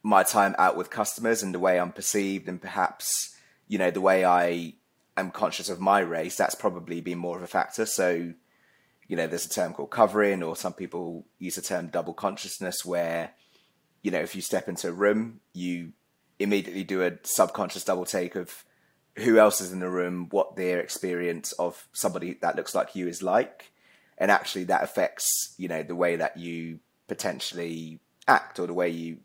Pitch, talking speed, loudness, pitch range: 90 Hz, 195 wpm, -27 LUFS, 85-95 Hz